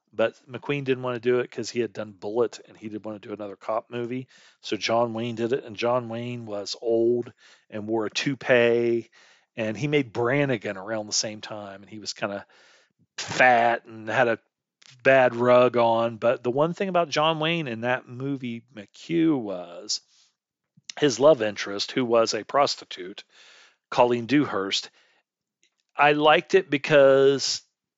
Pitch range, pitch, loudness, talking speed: 110-135 Hz, 120 Hz, -24 LUFS, 170 wpm